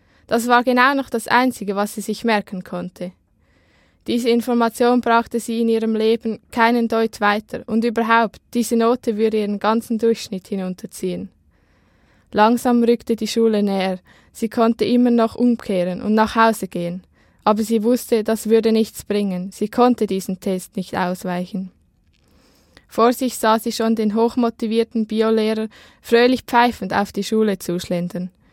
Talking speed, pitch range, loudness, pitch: 150 wpm, 200-235 Hz, -19 LUFS, 225 Hz